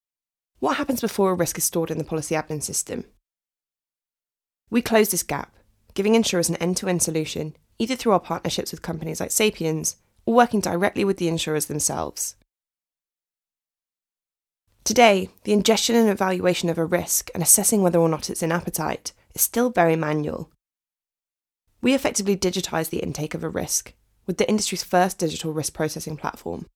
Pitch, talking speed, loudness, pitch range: 175 Hz, 165 wpm, -22 LUFS, 160-205 Hz